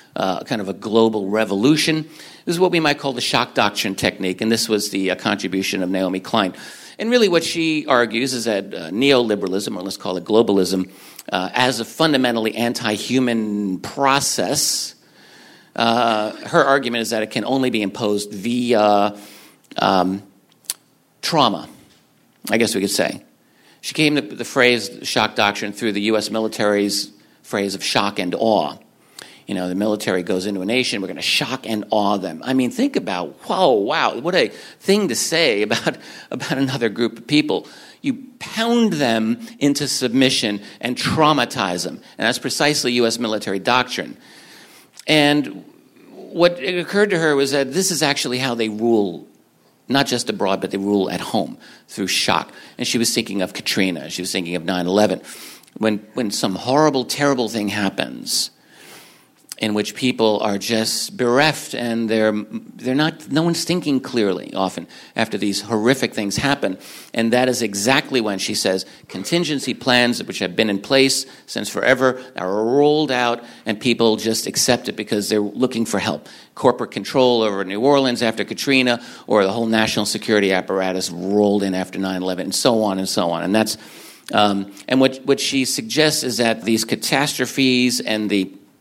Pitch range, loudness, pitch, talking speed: 105-135 Hz, -19 LUFS, 115 Hz, 175 wpm